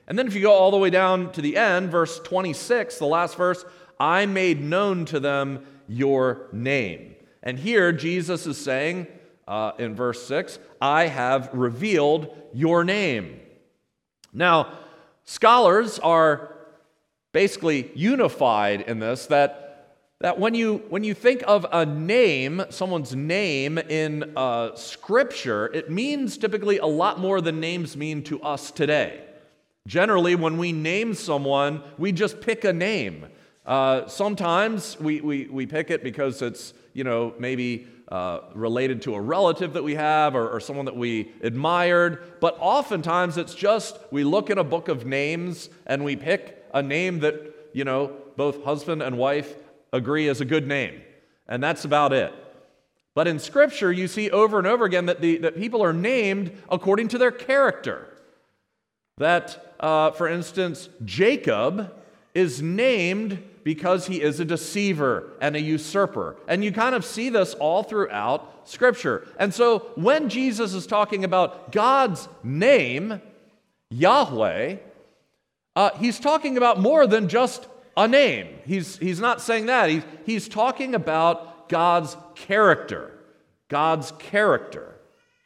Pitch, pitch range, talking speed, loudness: 170 Hz, 145-200 Hz, 150 wpm, -23 LUFS